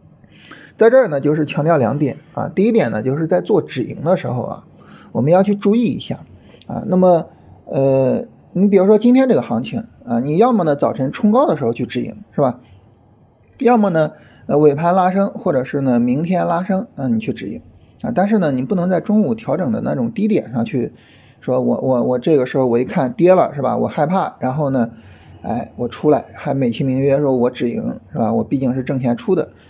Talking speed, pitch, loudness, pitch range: 300 characters per minute, 150 Hz, -17 LUFS, 130-195 Hz